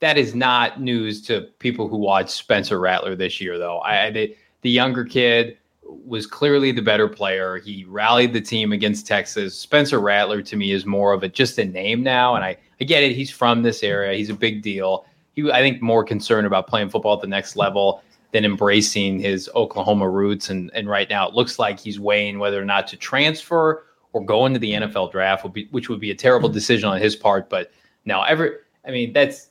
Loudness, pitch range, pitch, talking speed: -20 LUFS, 100-125 Hz, 105 Hz, 215 wpm